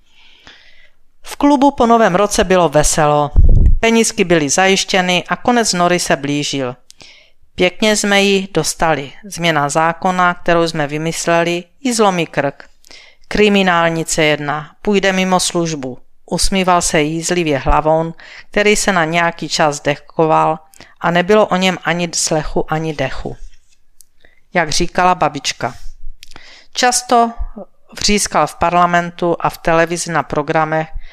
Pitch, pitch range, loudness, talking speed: 170 Hz, 155-190 Hz, -14 LUFS, 120 wpm